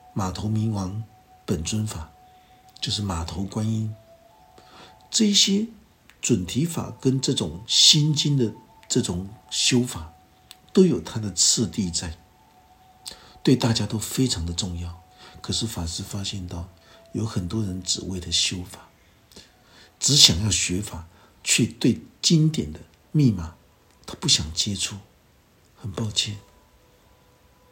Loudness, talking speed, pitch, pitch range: -22 LUFS, 175 characters per minute, 105 Hz, 90-120 Hz